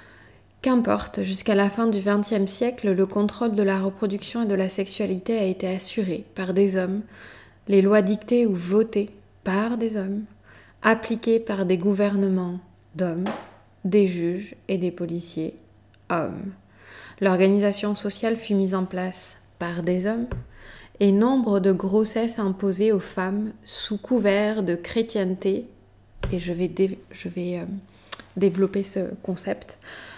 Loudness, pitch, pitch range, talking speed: -24 LUFS, 195 Hz, 180-210 Hz, 140 wpm